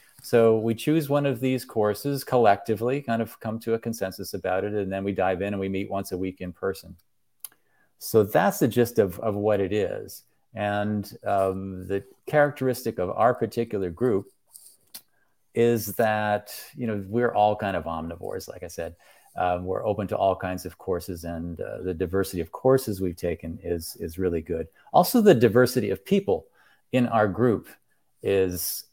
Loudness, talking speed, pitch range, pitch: -25 LUFS, 180 wpm, 95-120 Hz, 105 Hz